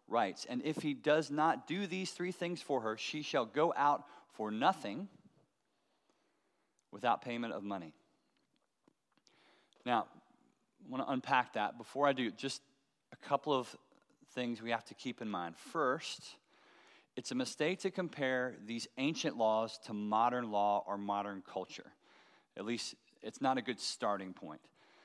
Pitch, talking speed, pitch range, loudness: 125 Hz, 155 wpm, 110-150 Hz, -37 LUFS